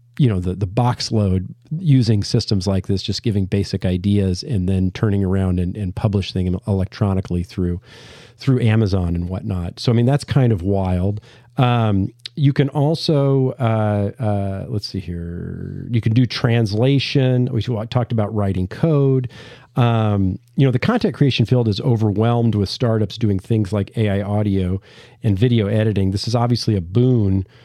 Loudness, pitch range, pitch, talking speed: -19 LUFS, 100-125 Hz, 110 Hz, 165 wpm